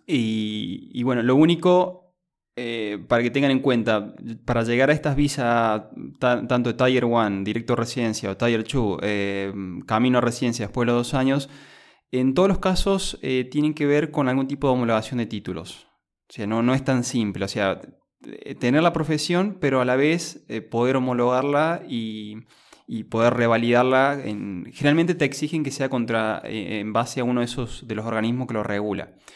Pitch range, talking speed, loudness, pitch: 110-140 Hz, 180 wpm, -23 LUFS, 125 Hz